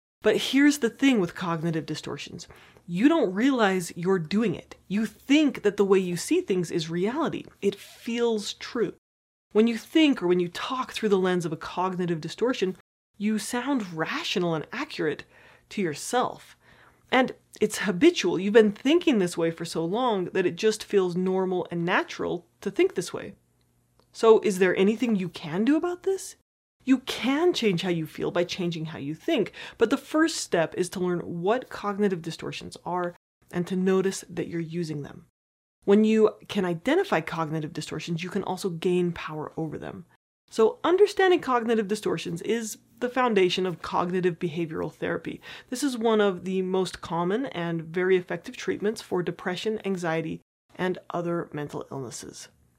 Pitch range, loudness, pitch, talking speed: 175-230 Hz, -26 LUFS, 190 Hz, 170 wpm